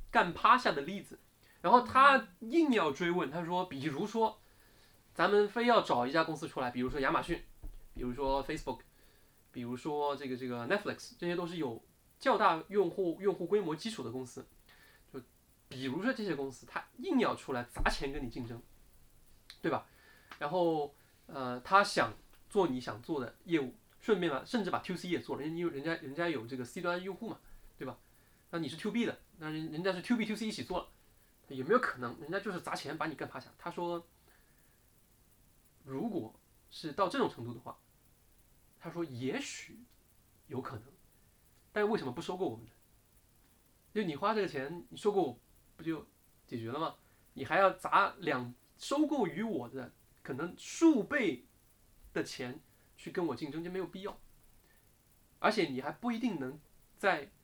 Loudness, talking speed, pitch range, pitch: -34 LUFS, 265 characters per minute, 130-195 Hz, 160 Hz